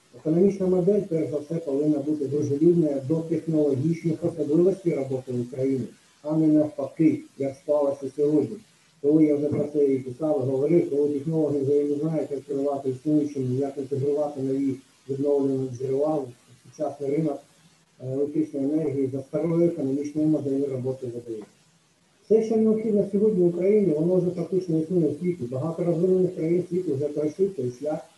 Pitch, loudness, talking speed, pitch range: 150 Hz, -25 LUFS, 145 wpm, 140-165 Hz